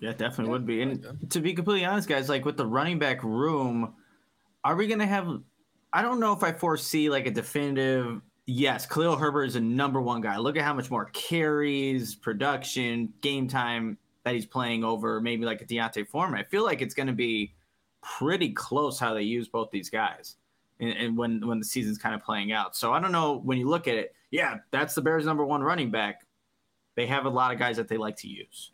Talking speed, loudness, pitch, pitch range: 225 wpm, -28 LUFS, 130 Hz, 115-150 Hz